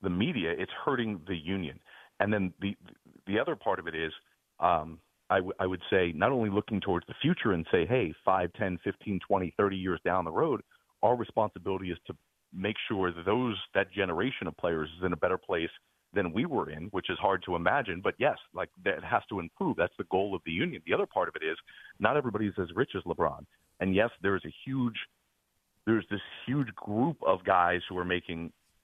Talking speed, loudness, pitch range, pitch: 215 wpm, -31 LUFS, 90-105 Hz, 95 Hz